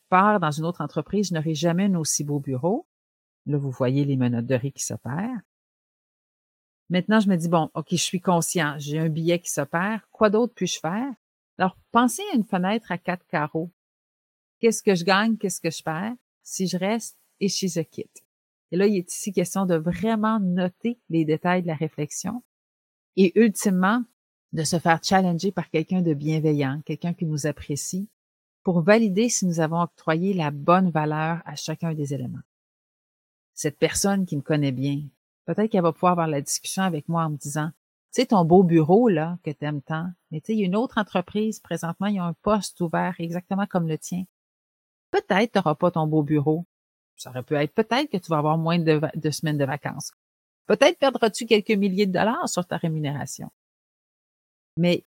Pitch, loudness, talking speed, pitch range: 175 Hz, -24 LUFS, 200 wpm, 155-200 Hz